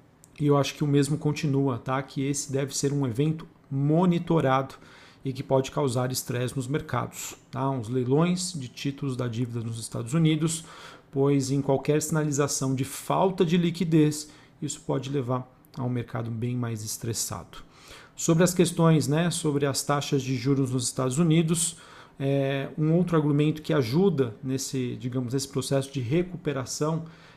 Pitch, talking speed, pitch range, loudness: 140 Hz, 160 wpm, 130-155 Hz, -26 LUFS